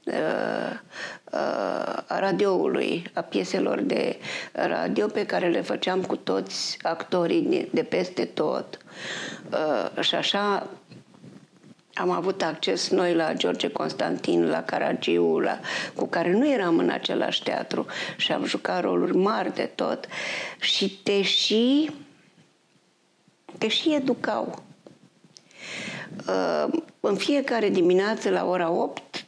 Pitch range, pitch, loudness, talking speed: 180-280 Hz, 200 Hz, -25 LUFS, 110 wpm